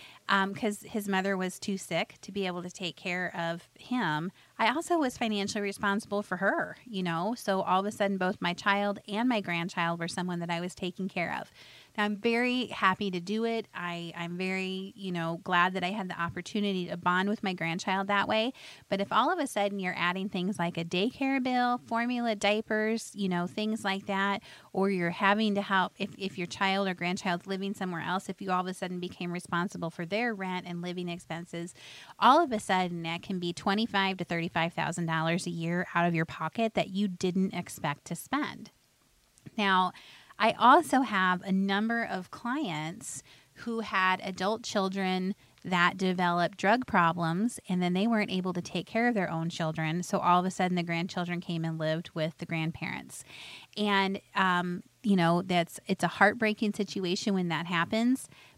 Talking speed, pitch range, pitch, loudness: 200 wpm, 175-205 Hz, 190 Hz, -30 LUFS